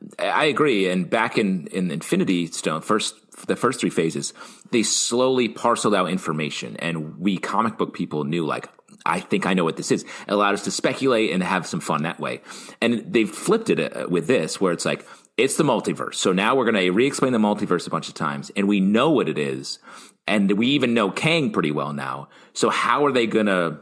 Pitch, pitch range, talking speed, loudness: 95 Hz, 80-110 Hz, 215 wpm, -22 LUFS